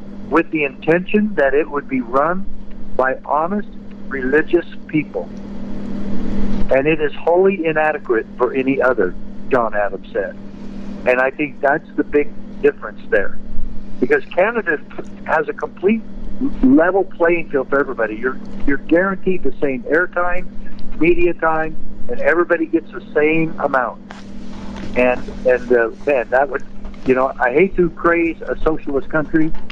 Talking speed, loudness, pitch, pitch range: 140 wpm, -18 LUFS, 175 Hz, 150-210 Hz